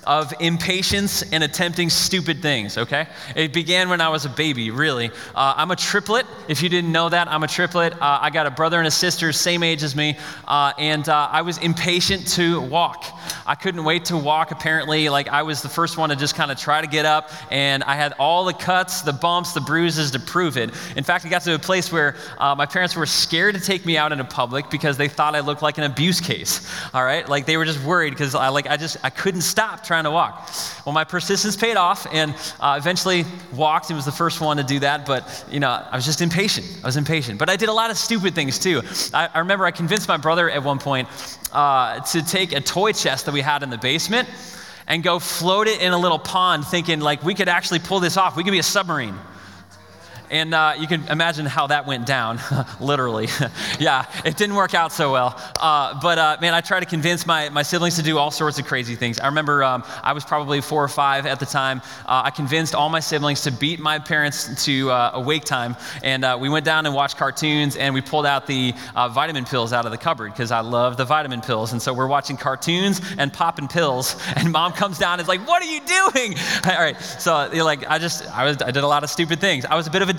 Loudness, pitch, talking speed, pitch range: -20 LUFS, 155 Hz, 250 wpm, 140-175 Hz